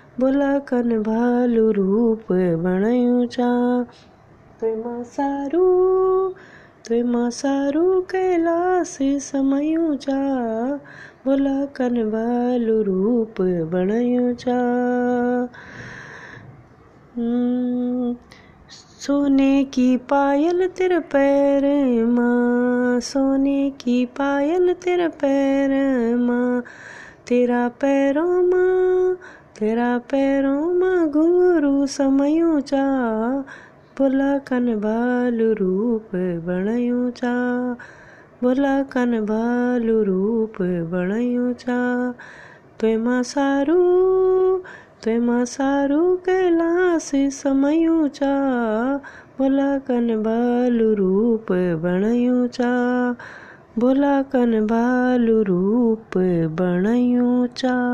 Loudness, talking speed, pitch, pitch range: -20 LUFS, 60 wpm, 245 Hz, 235-280 Hz